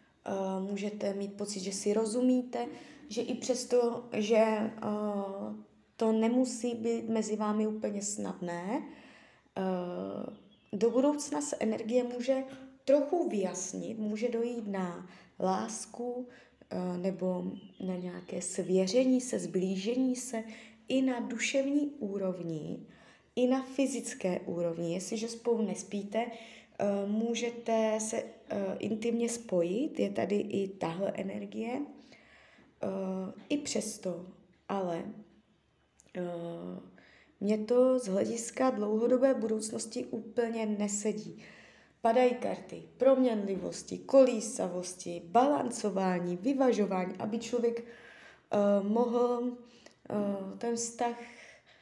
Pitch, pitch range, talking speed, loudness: 220 Hz, 195-245 Hz, 95 wpm, -32 LUFS